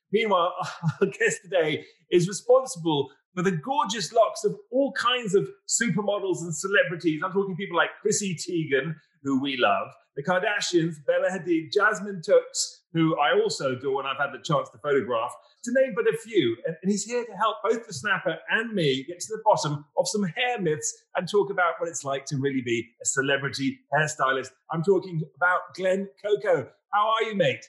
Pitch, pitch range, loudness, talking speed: 190 Hz, 160-220 Hz, -26 LUFS, 190 wpm